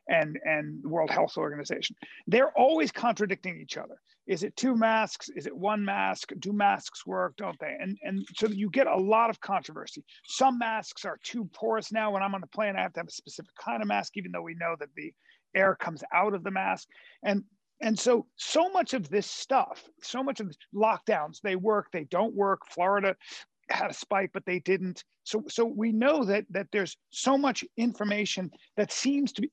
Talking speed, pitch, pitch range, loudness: 210 wpm, 205 Hz, 190-230 Hz, -29 LUFS